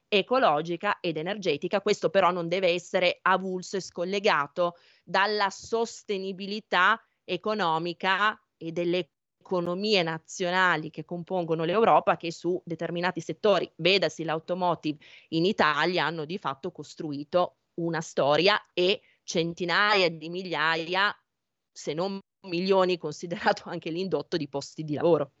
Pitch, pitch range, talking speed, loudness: 175 Hz, 165-190 Hz, 115 wpm, -27 LUFS